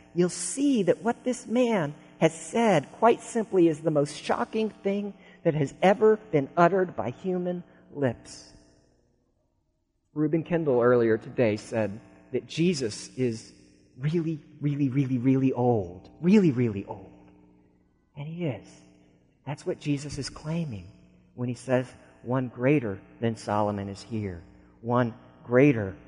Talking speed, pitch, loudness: 135 wpm, 135 Hz, -27 LUFS